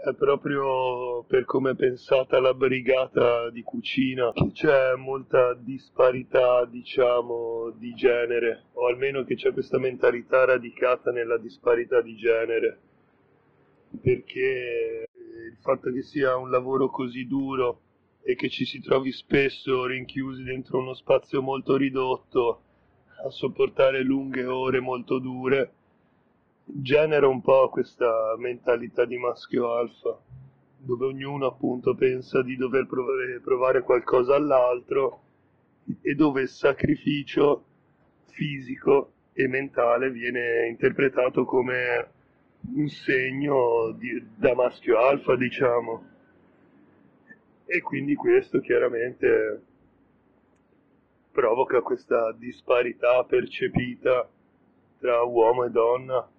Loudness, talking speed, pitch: -25 LUFS, 105 wpm, 135 Hz